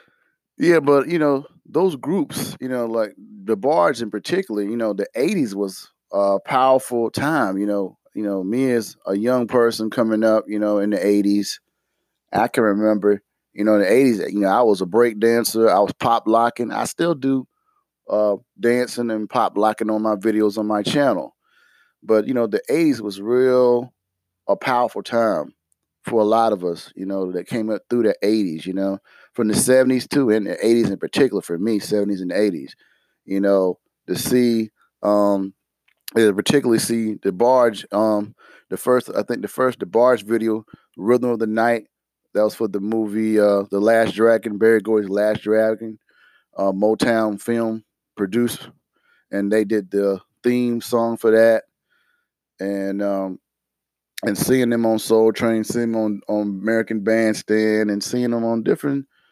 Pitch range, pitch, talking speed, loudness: 105-120 Hz, 110 Hz, 175 wpm, -20 LUFS